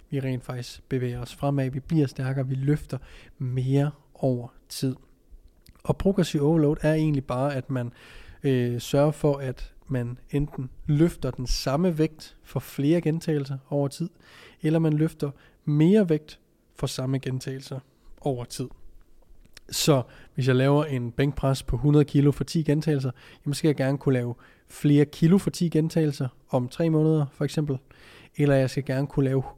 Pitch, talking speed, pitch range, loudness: 140 Hz, 165 wpm, 130-155 Hz, -26 LUFS